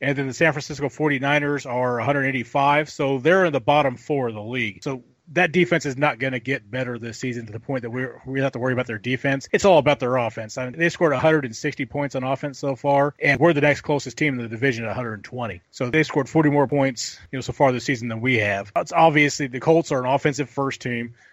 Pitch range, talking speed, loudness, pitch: 125-145 Hz, 255 wpm, -22 LUFS, 135 Hz